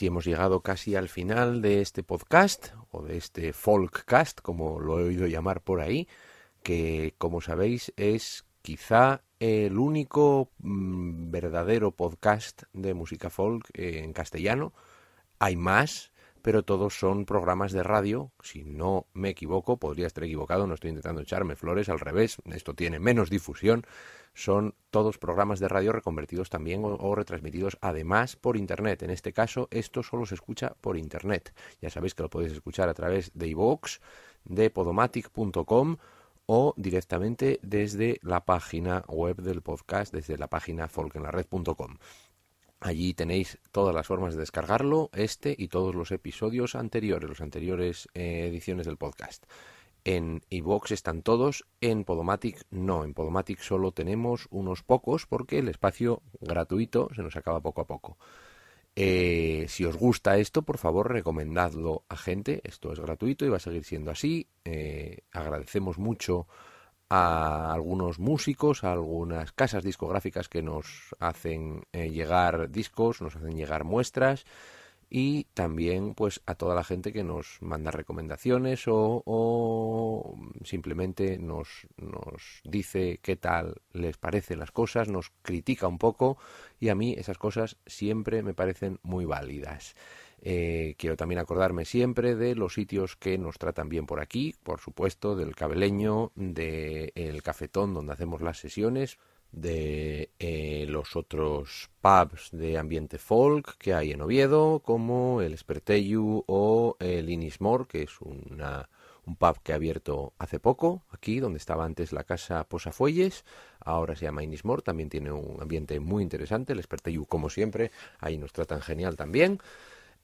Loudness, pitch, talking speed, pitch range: -29 LUFS, 90 Hz, 150 wpm, 80-105 Hz